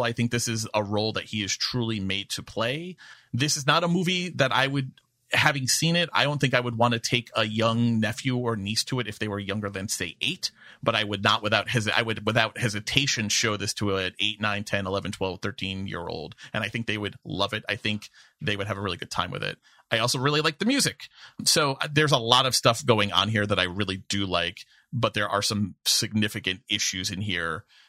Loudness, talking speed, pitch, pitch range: -25 LUFS, 245 wpm, 110 Hz, 100-125 Hz